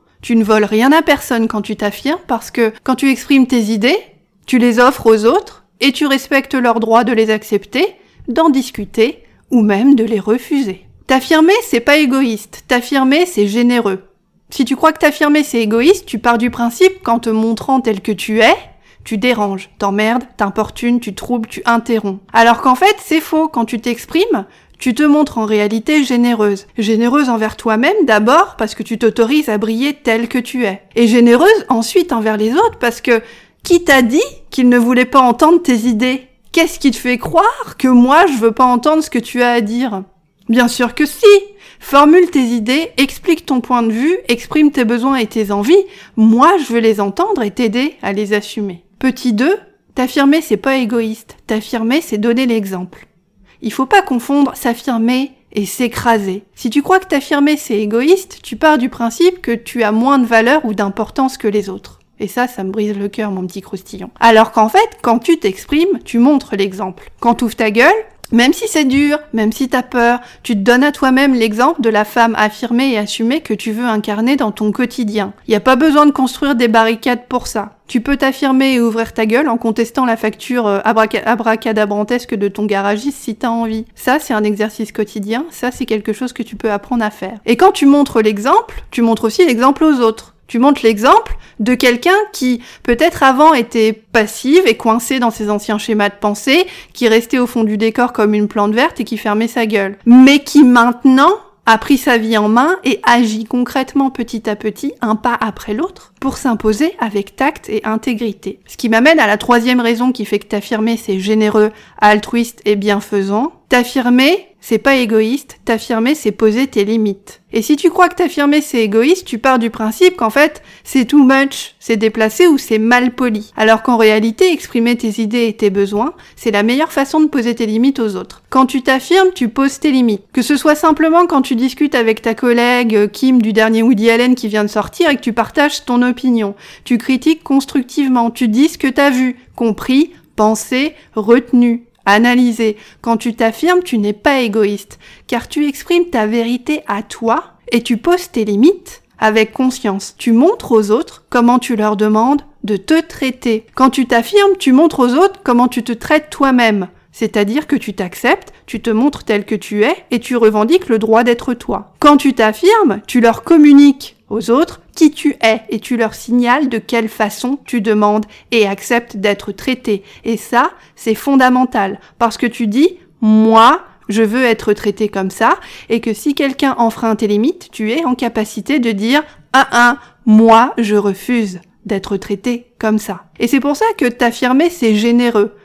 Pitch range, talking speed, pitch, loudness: 220-275 Hz, 195 wpm, 240 Hz, -13 LUFS